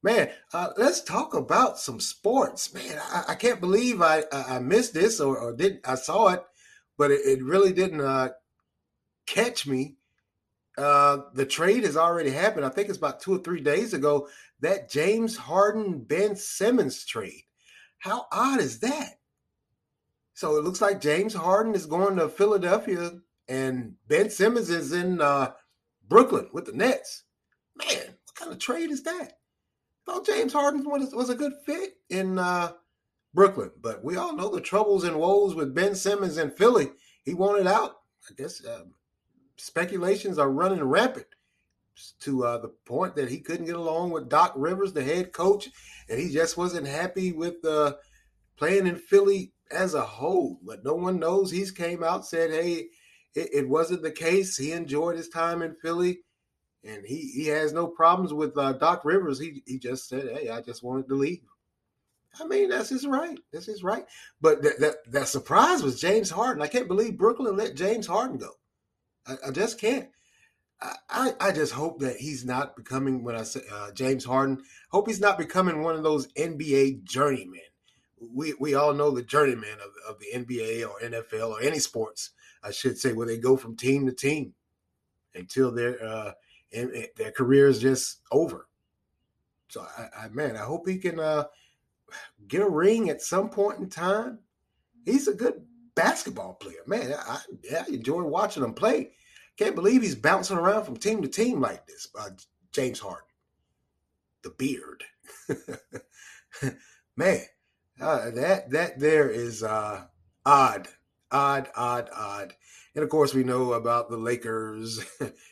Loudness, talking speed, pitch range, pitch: -26 LUFS, 175 wpm, 130-200 Hz, 165 Hz